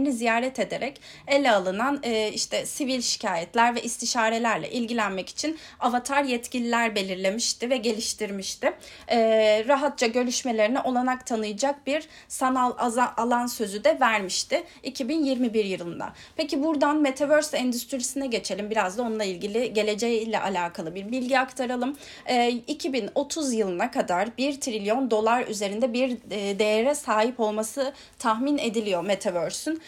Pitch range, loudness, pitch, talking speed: 215-270 Hz, -25 LUFS, 240 Hz, 125 wpm